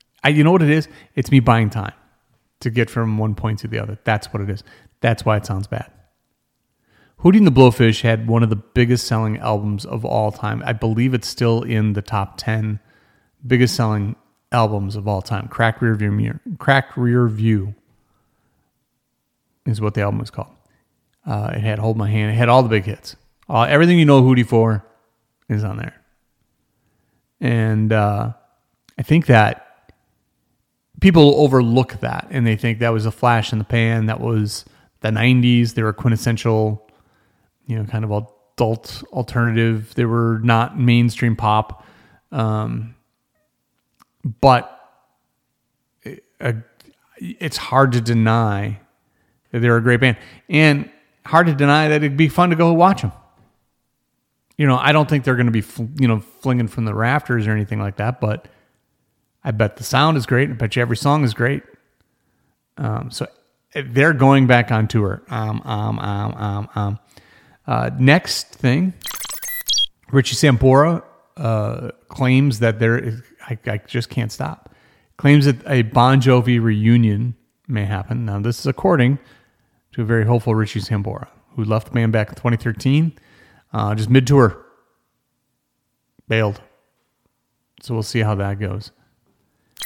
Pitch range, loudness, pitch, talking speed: 110-130 Hz, -18 LUFS, 115 Hz, 160 wpm